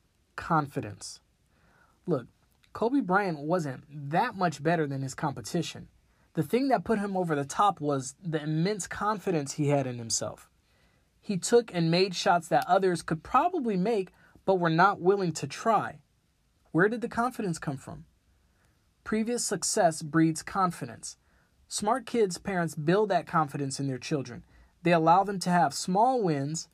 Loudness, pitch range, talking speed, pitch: -28 LUFS, 140-195 Hz, 155 wpm, 165 Hz